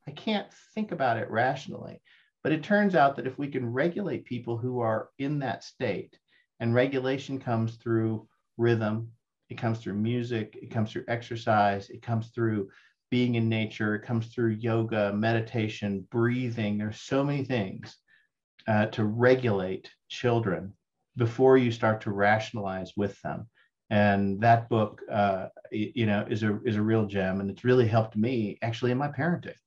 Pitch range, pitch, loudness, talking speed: 105-125 Hz, 115 Hz, -28 LUFS, 165 wpm